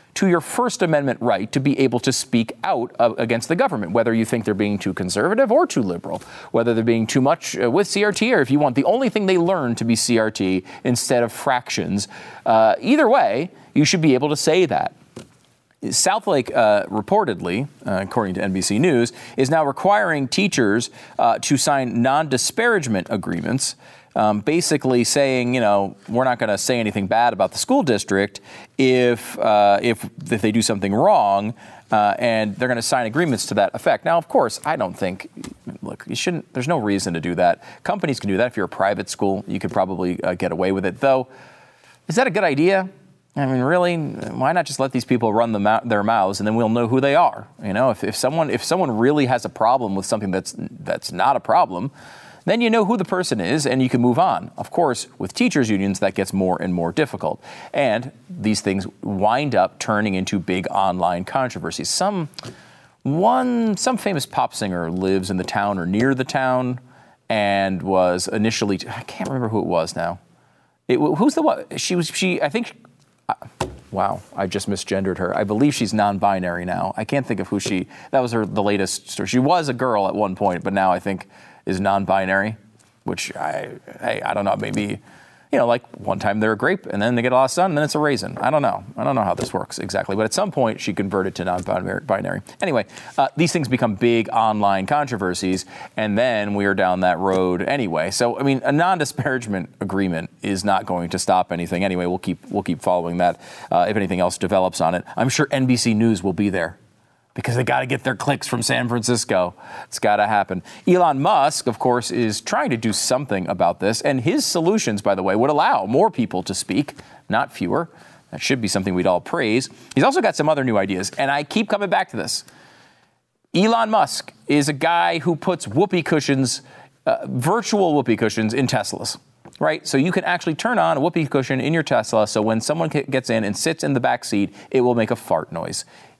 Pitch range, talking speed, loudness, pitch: 100-140 Hz, 215 wpm, -20 LUFS, 115 Hz